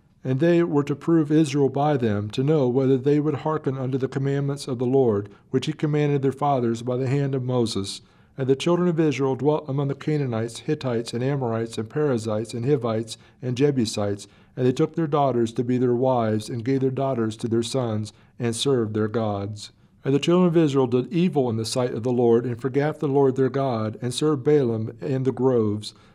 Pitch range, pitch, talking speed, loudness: 115-145 Hz, 130 Hz, 215 wpm, -23 LUFS